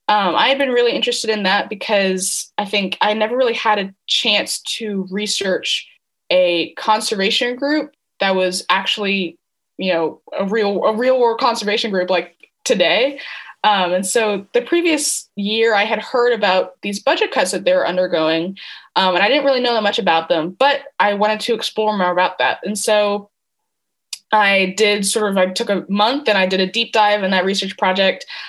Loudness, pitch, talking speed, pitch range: -17 LUFS, 210 Hz, 190 wpm, 190-230 Hz